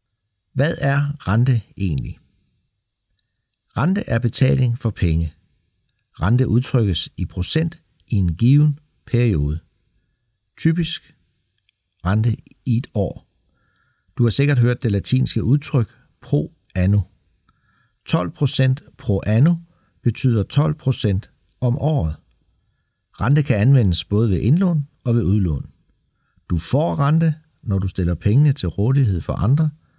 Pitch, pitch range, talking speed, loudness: 120 Hz, 100-140 Hz, 120 wpm, -19 LUFS